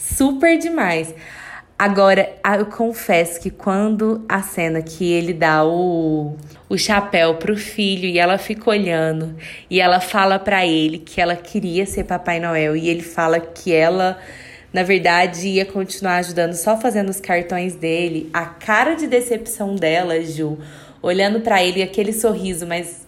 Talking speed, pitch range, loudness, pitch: 155 wpm, 165-200 Hz, -18 LUFS, 180 Hz